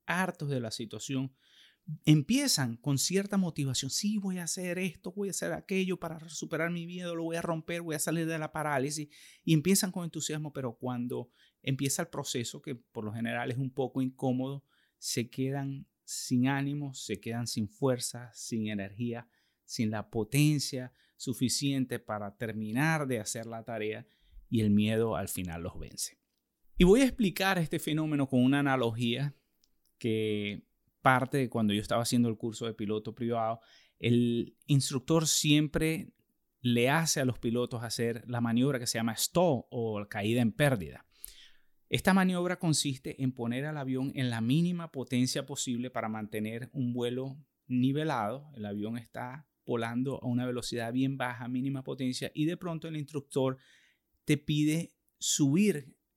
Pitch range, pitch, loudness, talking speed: 120-155 Hz, 130 Hz, -32 LUFS, 160 wpm